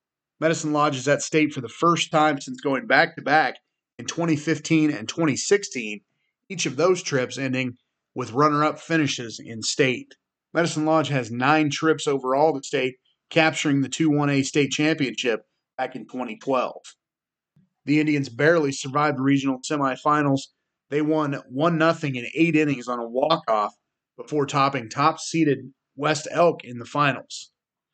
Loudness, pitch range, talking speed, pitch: -23 LUFS, 135-155 Hz, 145 wpm, 145 Hz